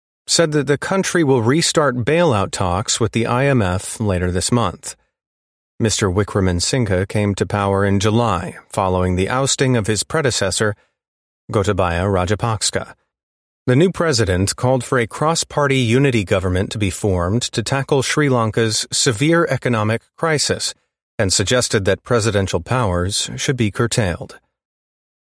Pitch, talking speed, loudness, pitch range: 115 Hz, 135 wpm, -17 LUFS, 95-130 Hz